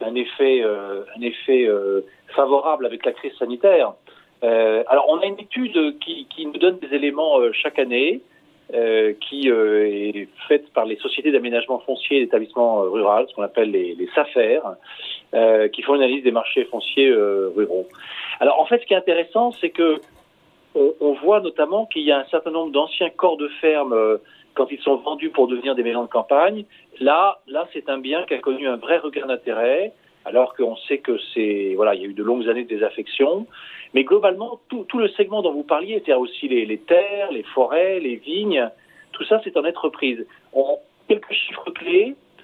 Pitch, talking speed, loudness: 155 Hz, 200 wpm, -20 LUFS